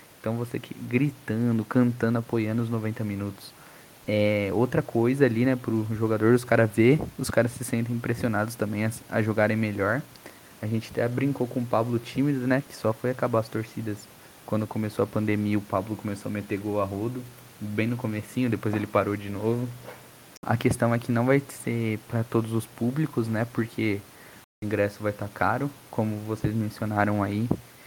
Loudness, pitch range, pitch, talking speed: -27 LUFS, 105-120 Hz, 115 Hz, 190 wpm